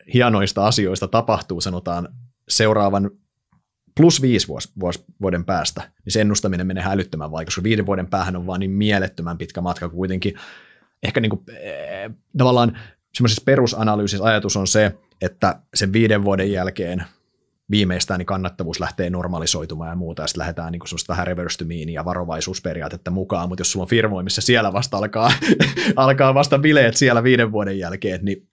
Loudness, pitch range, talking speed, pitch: -20 LUFS, 90-110 Hz, 155 wpm, 95 Hz